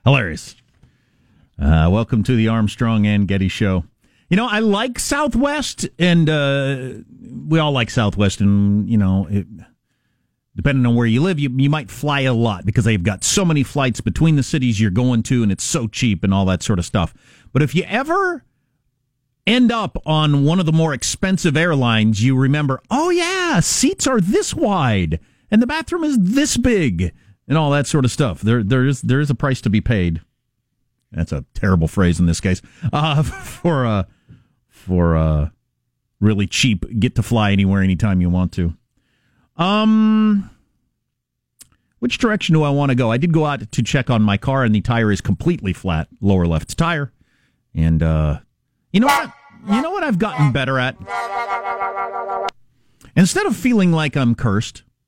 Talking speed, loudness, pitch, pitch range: 180 wpm, -18 LUFS, 125 Hz, 105-160 Hz